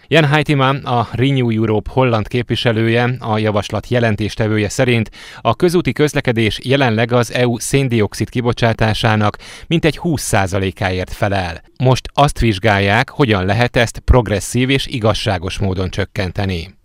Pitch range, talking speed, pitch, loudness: 105-130 Hz, 120 wpm, 115 Hz, -16 LUFS